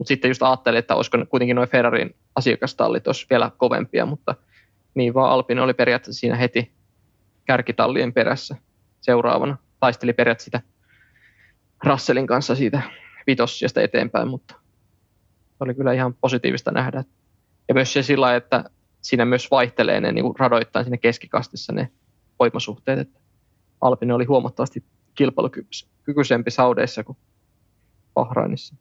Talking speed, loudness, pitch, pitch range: 125 wpm, -21 LUFS, 120 Hz, 110-130 Hz